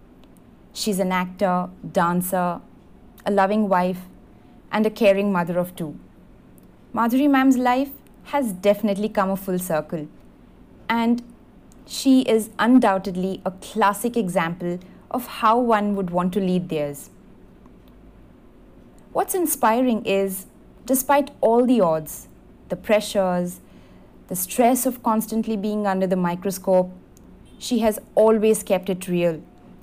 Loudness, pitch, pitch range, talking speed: -21 LUFS, 200 Hz, 180-230 Hz, 120 wpm